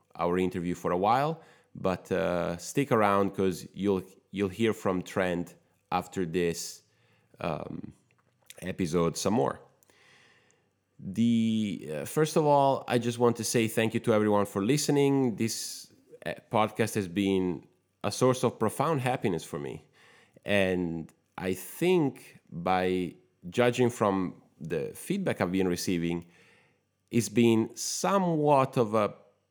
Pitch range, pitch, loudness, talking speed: 90-120 Hz, 105 Hz, -29 LUFS, 130 wpm